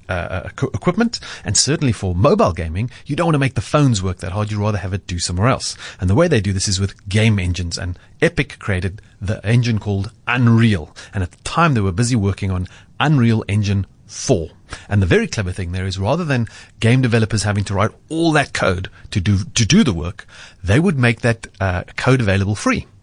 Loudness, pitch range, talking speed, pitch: -18 LUFS, 95-120 Hz, 220 wpm, 105 Hz